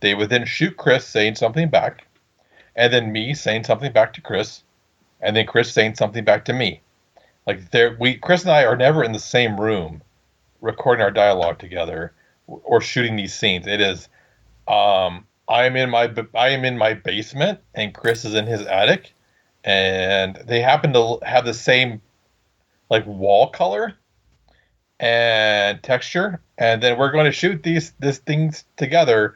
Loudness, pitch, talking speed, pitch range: -18 LUFS, 115 Hz, 170 wpm, 105-130 Hz